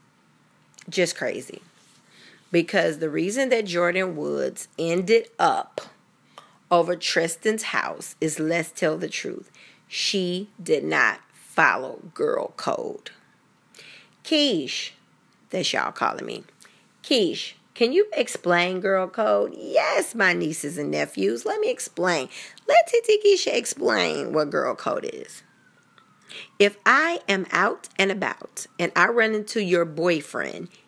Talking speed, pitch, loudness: 120 wpm, 195 Hz, -23 LUFS